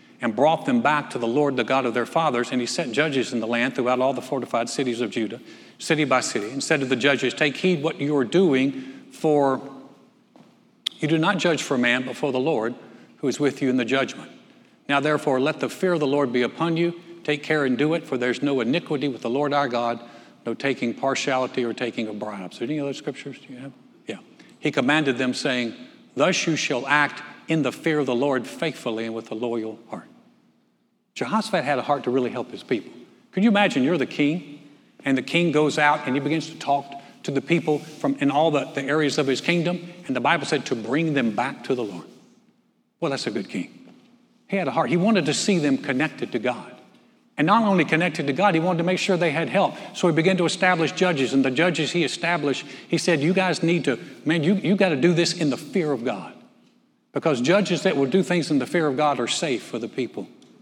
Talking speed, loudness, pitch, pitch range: 240 wpm, -23 LUFS, 145 Hz, 130-170 Hz